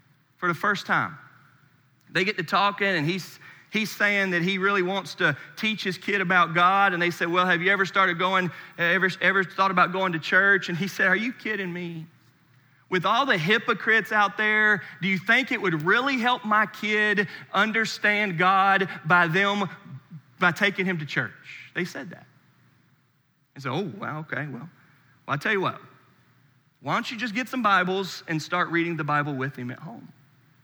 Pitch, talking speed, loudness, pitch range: 185 Hz, 195 wpm, -23 LUFS, 160-200 Hz